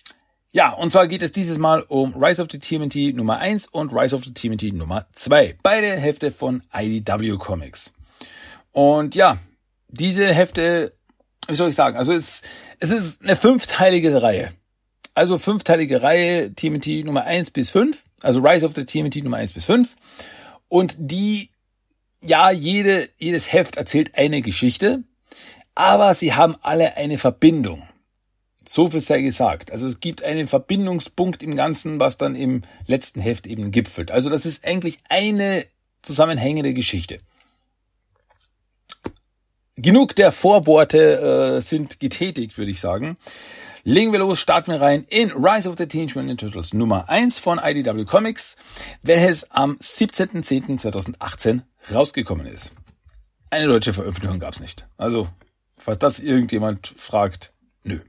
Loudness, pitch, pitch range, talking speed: -19 LUFS, 150 Hz, 115-175 Hz, 145 wpm